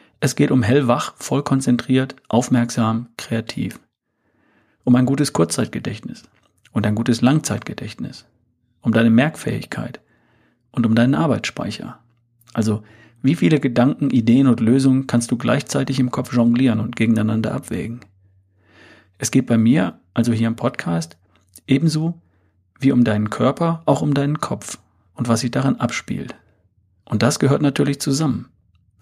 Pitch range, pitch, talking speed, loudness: 110-135 Hz, 120 Hz, 135 wpm, -19 LUFS